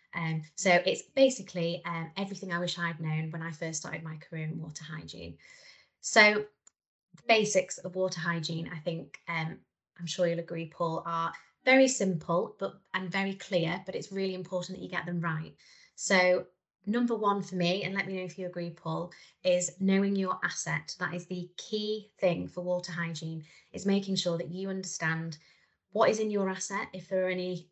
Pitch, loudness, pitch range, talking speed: 180 Hz, -31 LUFS, 170-195 Hz, 195 wpm